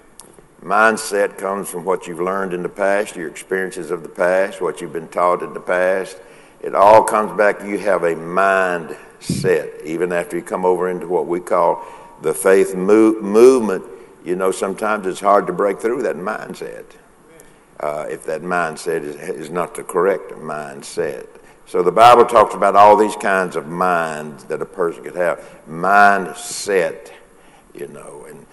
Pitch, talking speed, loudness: 105 Hz, 170 wpm, -17 LUFS